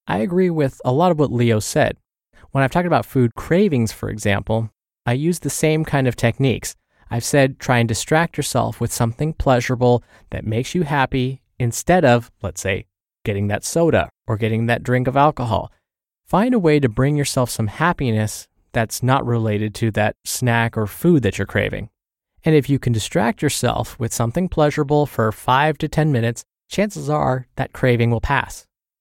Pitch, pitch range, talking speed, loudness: 125 Hz, 110-150 Hz, 185 wpm, -19 LUFS